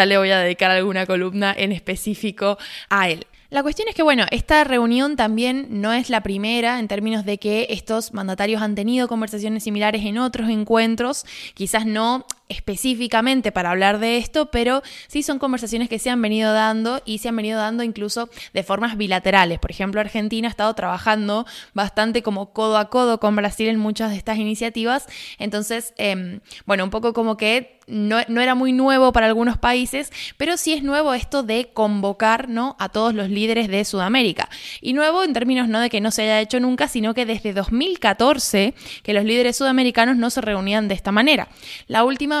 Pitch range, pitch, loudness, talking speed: 210-245 Hz, 225 Hz, -20 LUFS, 190 wpm